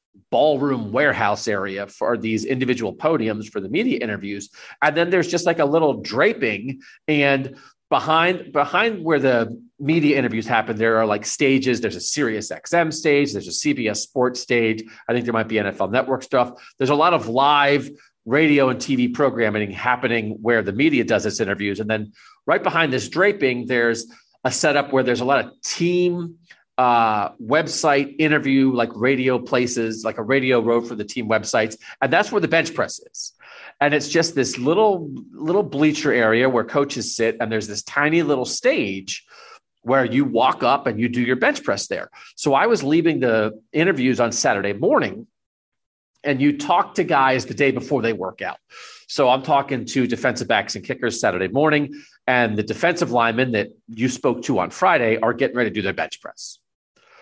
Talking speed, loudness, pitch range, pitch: 185 wpm, -20 LUFS, 115-145 Hz, 130 Hz